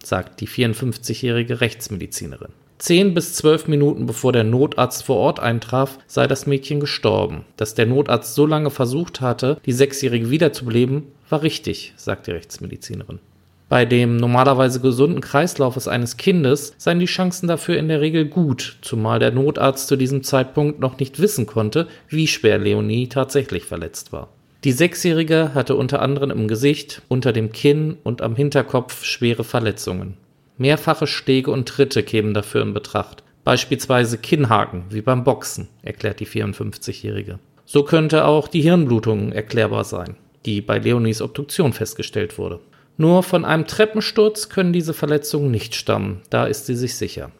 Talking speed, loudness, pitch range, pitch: 155 wpm, -19 LUFS, 115-150 Hz, 135 Hz